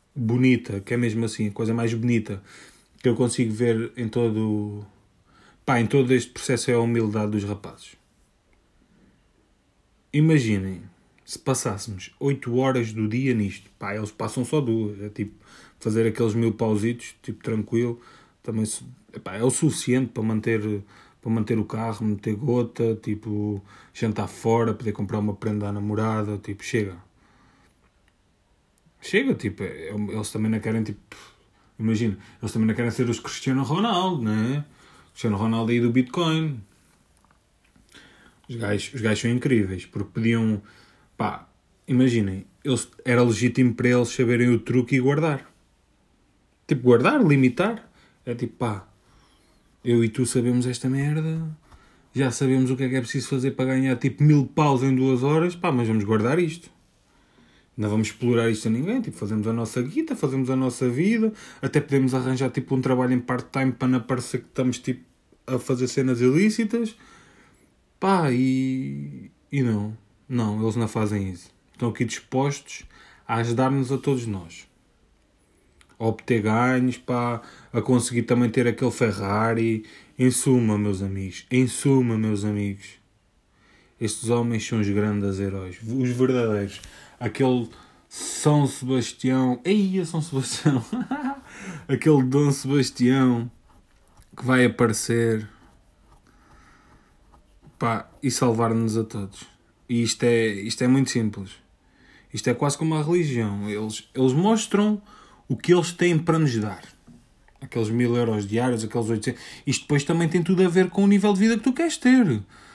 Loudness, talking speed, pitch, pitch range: -24 LUFS, 150 wpm, 120 Hz, 110-130 Hz